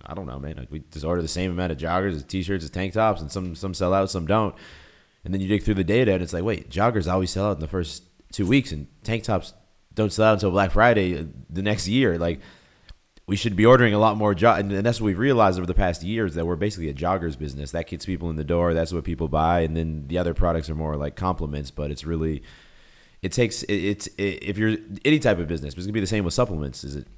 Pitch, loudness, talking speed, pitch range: 90 Hz, -24 LUFS, 280 wpm, 80-105 Hz